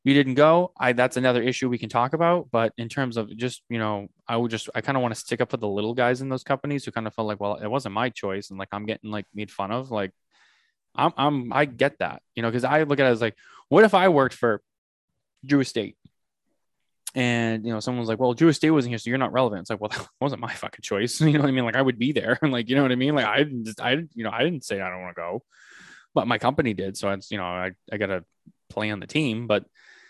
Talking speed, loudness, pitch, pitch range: 290 wpm, -24 LUFS, 120 Hz, 105-135 Hz